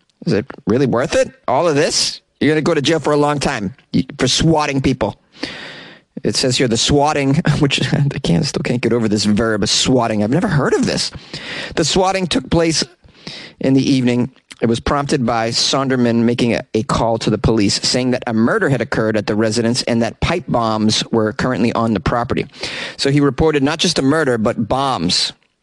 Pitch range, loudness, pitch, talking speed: 115-150 Hz, -16 LUFS, 130 Hz, 205 wpm